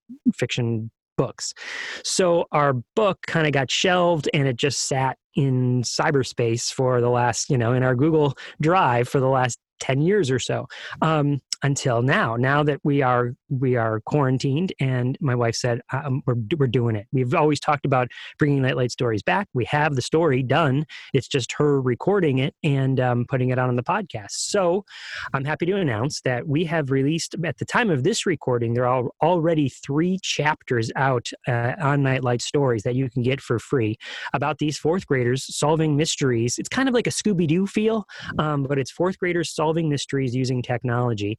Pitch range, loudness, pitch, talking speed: 125-155 Hz, -22 LUFS, 135 Hz, 190 wpm